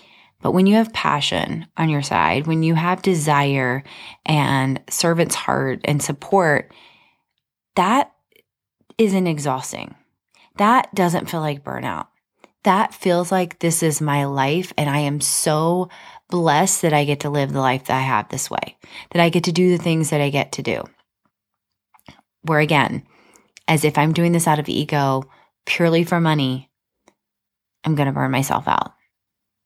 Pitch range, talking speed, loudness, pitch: 140-175 Hz, 160 wpm, -19 LUFS, 155 Hz